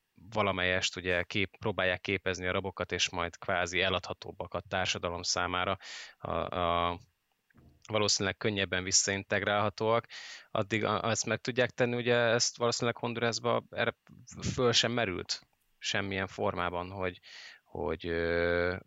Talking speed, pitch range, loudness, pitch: 110 wpm, 90-110 Hz, -31 LUFS, 100 Hz